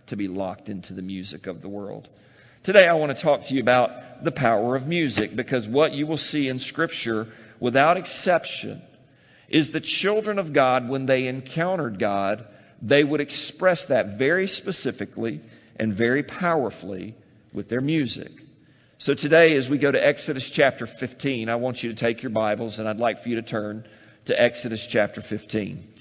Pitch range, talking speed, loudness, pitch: 110-145 Hz, 180 wpm, -23 LUFS, 125 Hz